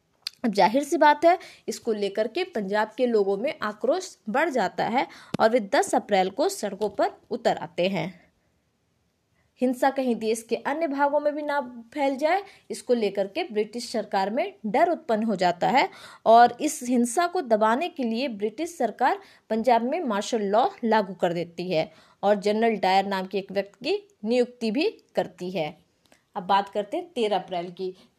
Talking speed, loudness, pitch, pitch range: 175 wpm, -25 LUFS, 225 Hz, 200-285 Hz